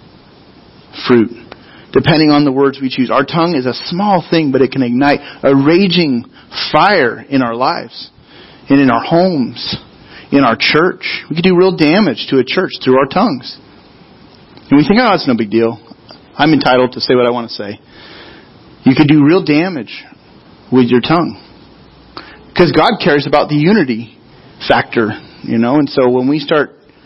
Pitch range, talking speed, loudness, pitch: 125-165 Hz, 175 wpm, -12 LUFS, 140 Hz